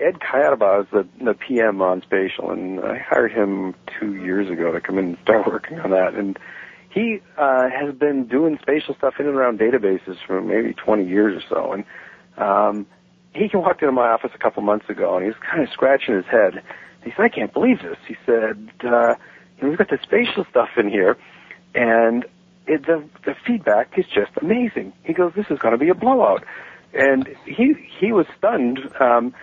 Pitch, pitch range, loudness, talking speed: 125 Hz, 105-165 Hz, -20 LUFS, 200 wpm